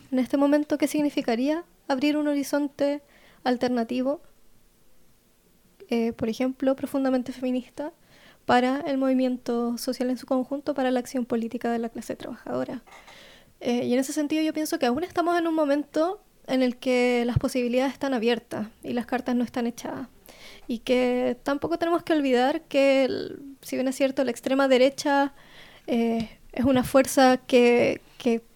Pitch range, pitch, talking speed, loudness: 250-290 Hz, 265 Hz, 160 wpm, -25 LUFS